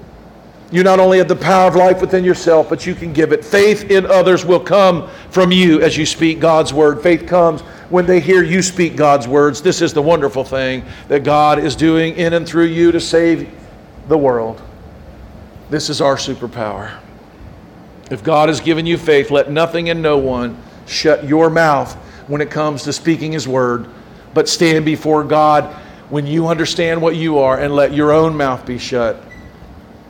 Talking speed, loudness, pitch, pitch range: 190 wpm, -13 LUFS, 155 Hz, 145-170 Hz